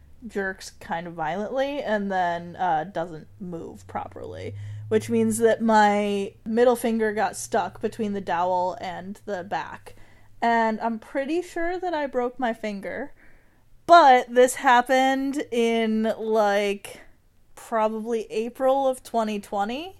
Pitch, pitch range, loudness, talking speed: 220 Hz, 200-250 Hz, -23 LUFS, 125 wpm